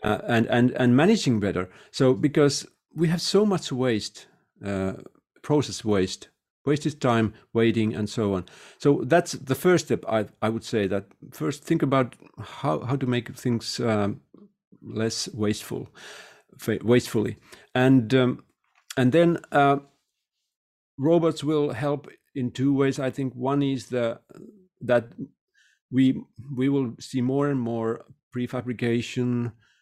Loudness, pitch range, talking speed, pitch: -25 LUFS, 115-145 Hz, 140 wpm, 125 Hz